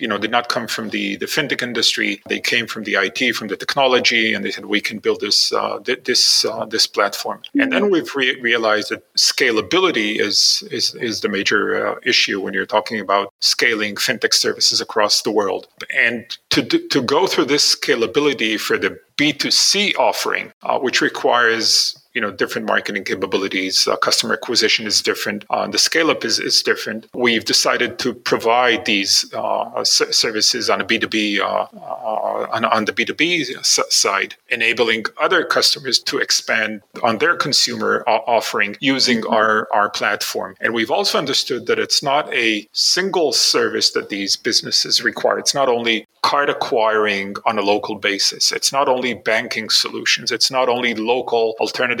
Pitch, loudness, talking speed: 120 Hz, -17 LUFS, 175 wpm